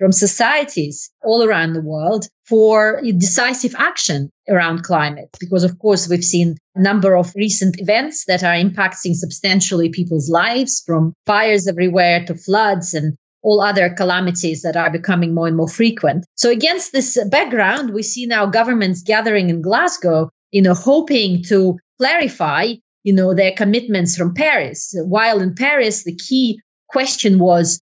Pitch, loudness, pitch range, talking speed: 190 Hz, -16 LUFS, 175-220 Hz, 155 wpm